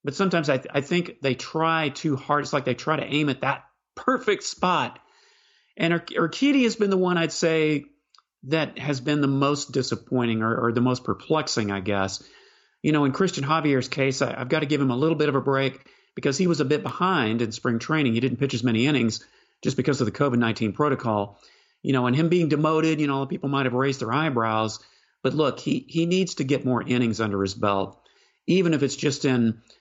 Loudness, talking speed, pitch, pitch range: -24 LUFS, 225 wpm, 140 Hz, 120-155 Hz